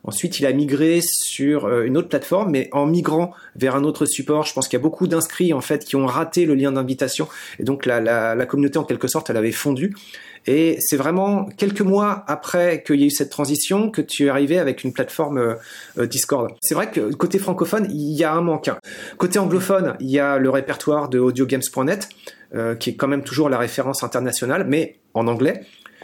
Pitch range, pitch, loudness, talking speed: 135-170 Hz, 150 Hz, -20 LUFS, 220 wpm